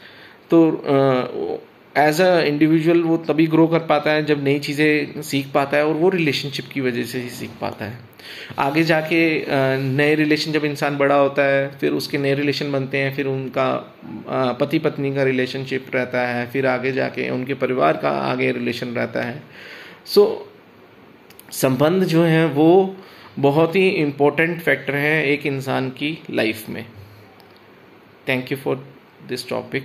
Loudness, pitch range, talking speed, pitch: -19 LUFS, 130-155 Hz, 165 wpm, 140 Hz